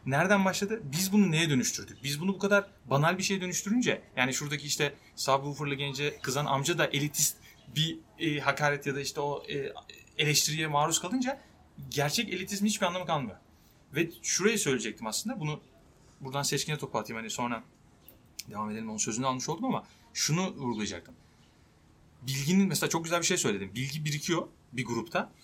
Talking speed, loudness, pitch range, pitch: 165 wpm, -30 LUFS, 135-175 Hz, 150 Hz